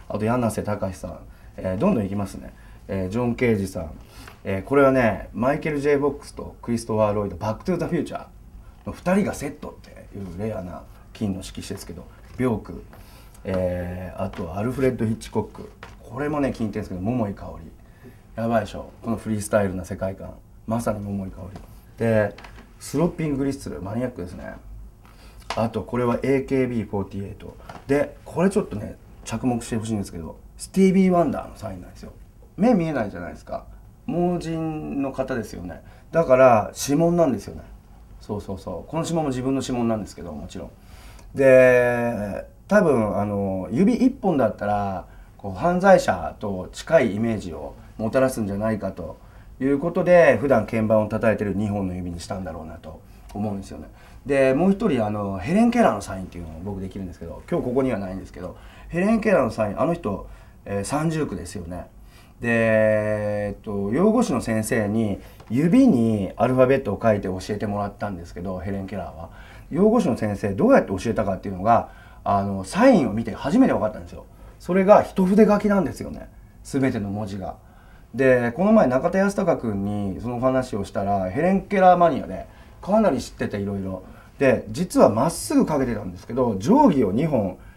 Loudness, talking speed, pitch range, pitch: -22 LUFS, 390 characters per minute, 95-130 Hz, 110 Hz